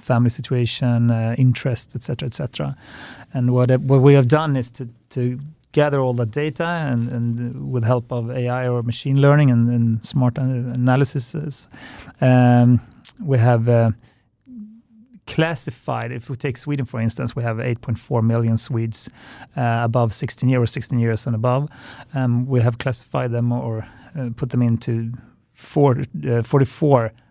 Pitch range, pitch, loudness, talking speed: 120-135 Hz, 125 Hz, -20 LUFS, 150 wpm